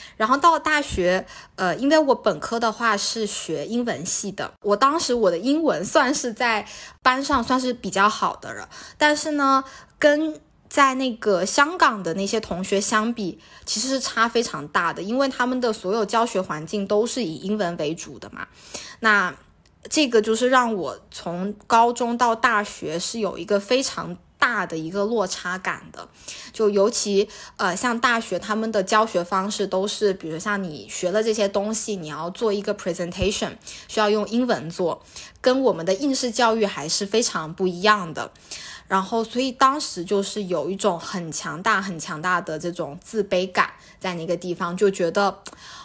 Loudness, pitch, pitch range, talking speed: -22 LUFS, 210 Hz, 185-245 Hz, 270 characters per minute